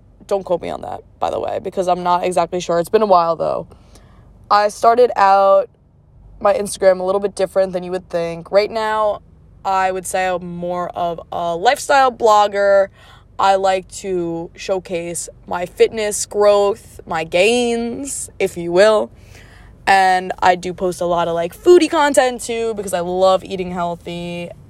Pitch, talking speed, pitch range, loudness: 185 Hz, 170 wpm, 175-205 Hz, -17 LUFS